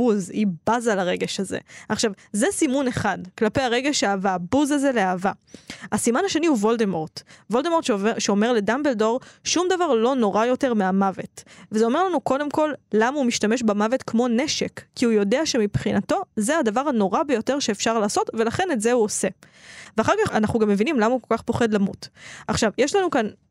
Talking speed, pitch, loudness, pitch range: 175 wpm, 230 Hz, -22 LUFS, 210-265 Hz